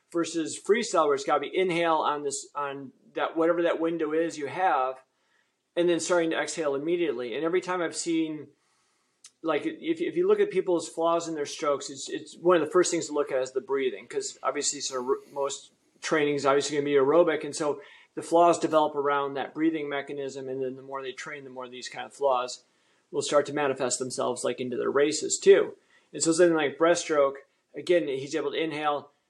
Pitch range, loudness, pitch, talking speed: 140-180 Hz, -27 LUFS, 160 Hz, 215 wpm